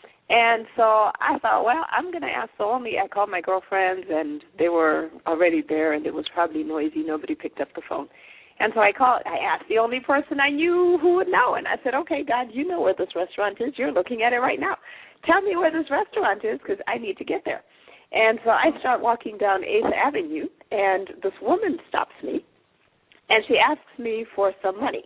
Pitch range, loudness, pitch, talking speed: 190-320 Hz, -23 LUFS, 235 Hz, 225 wpm